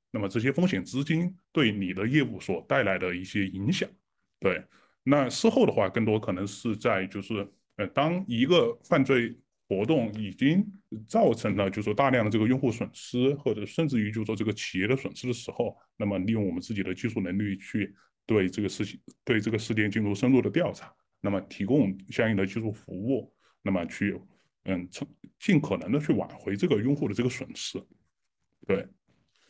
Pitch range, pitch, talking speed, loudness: 100-130 Hz, 110 Hz, 285 characters per minute, -28 LUFS